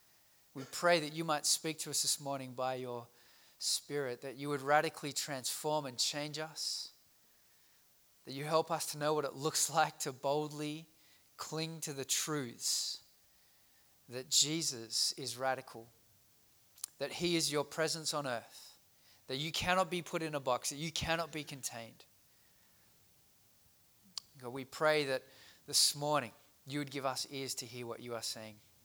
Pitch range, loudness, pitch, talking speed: 120-155 Hz, -36 LUFS, 140 Hz, 160 wpm